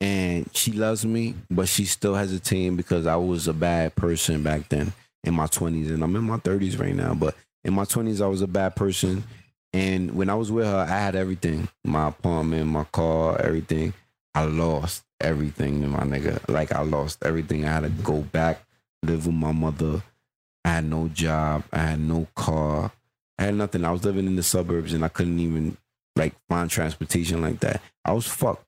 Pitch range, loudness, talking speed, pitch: 80-95 Hz, -25 LUFS, 205 wpm, 85 Hz